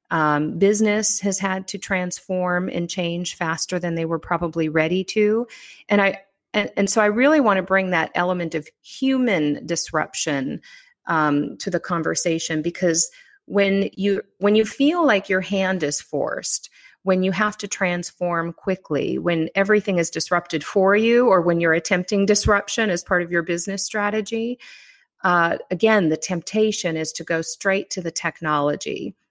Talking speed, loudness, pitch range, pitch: 160 wpm, -21 LUFS, 170-205 Hz, 185 Hz